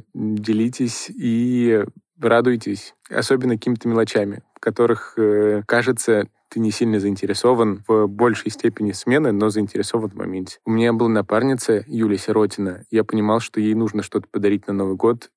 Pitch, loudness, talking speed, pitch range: 110 Hz, -20 LUFS, 150 wpm, 105-115 Hz